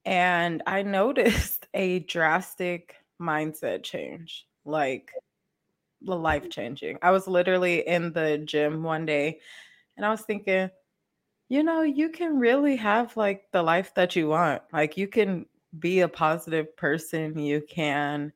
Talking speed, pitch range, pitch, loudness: 145 wpm, 155-195 Hz, 175 Hz, -26 LUFS